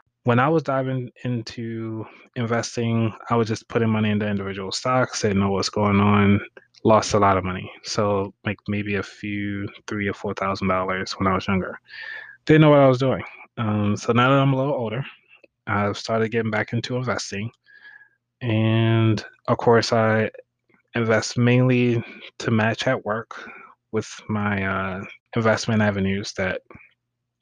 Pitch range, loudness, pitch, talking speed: 100-120 Hz, -22 LUFS, 110 Hz, 160 wpm